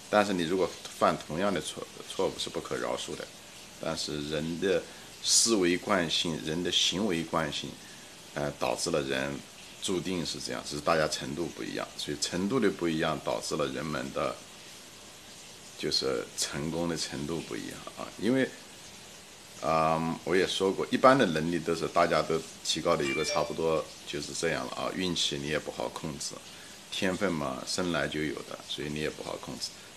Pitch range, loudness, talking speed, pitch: 75-85 Hz, -30 LUFS, 265 characters per minute, 80 Hz